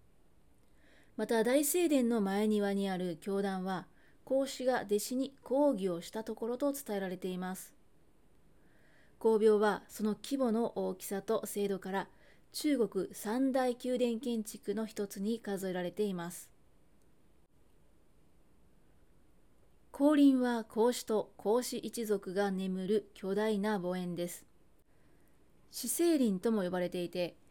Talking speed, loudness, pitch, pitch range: 225 characters per minute, -34 LUFS, 215 Hz, 190-245 Hz